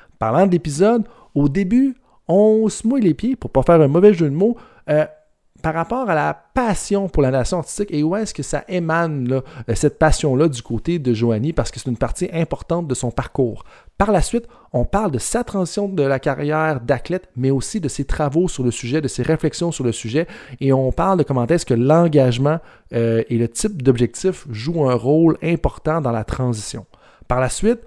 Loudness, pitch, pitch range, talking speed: -19 LUFS, 155 Hz, 130-185 Hz, 215 wpm